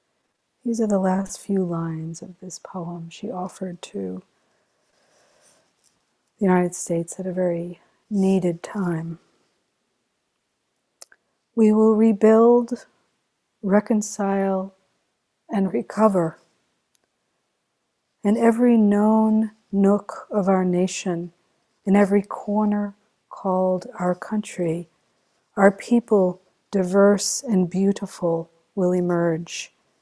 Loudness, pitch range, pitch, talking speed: -22 LUFS, 180-210 Hz, 195 Hz, 90 wpm